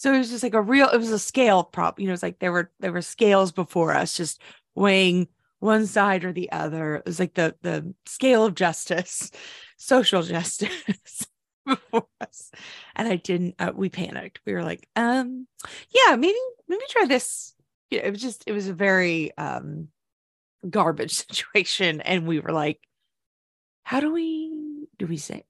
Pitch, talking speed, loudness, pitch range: 195 Hz, 185 wpm, -23 LUFS, 175-250 Hz